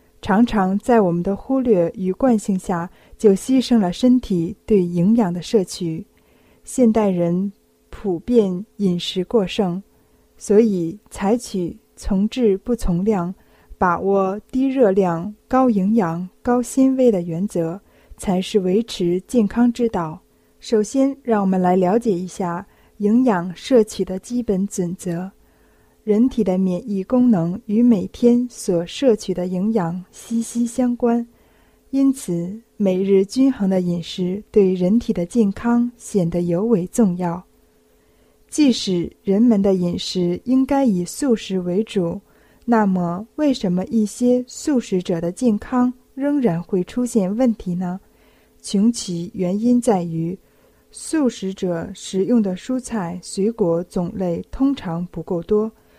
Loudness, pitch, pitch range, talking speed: -20 LUFS, 200 Hz, 180-235 Hz, 195 characters per minute